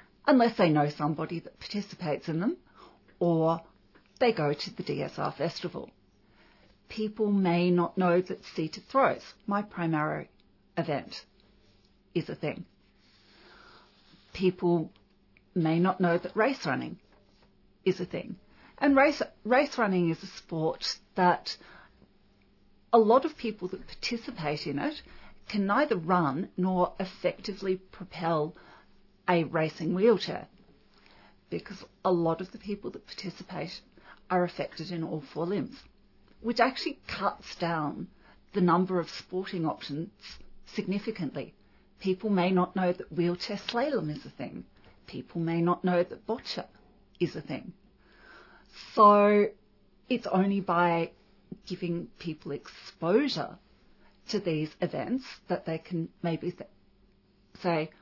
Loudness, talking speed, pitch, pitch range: -29 LUFS, 125 wpm, 180 Hz, 165-205 Hz